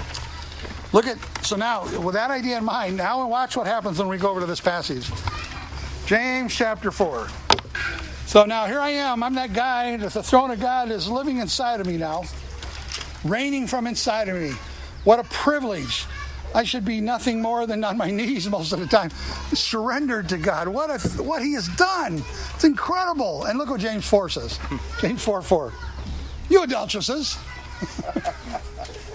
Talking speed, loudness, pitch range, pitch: 175 wpm, -23 LUFS, 175-255 Hz, 220 Hz